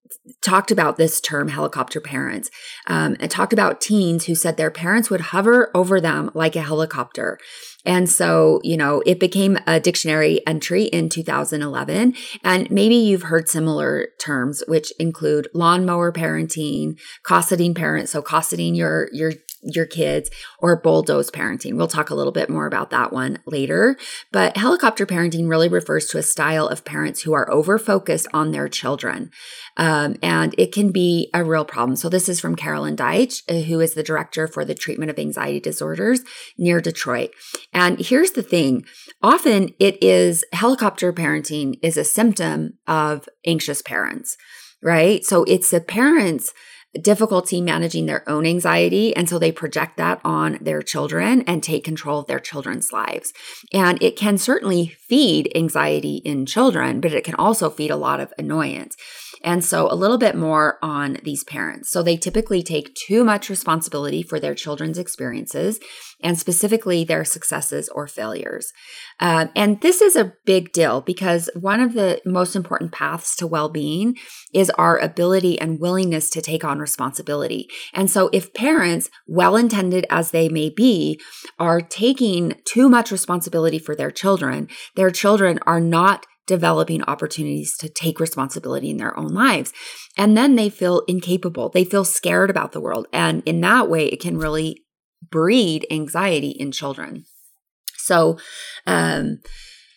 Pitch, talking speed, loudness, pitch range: 170 Hz, 165 wpm, -19 LUFS, 155-200 Hz